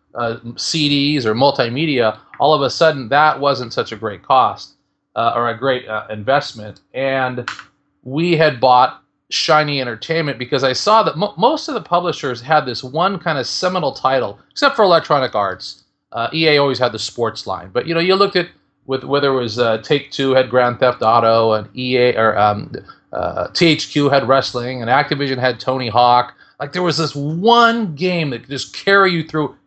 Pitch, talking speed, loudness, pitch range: 135 Hz, 190 wpm, -16 LUFS, 120-155 Hz